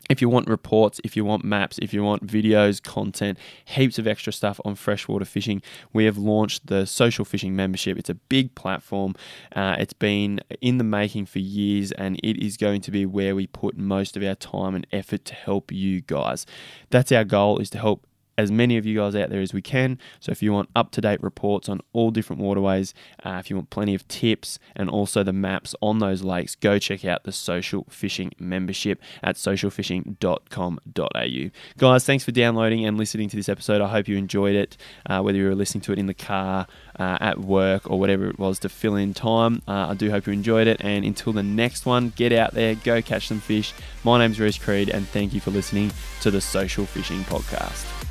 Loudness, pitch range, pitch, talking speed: -23 LUFS, 95-110 Hz, 100 Hz, 220 wpm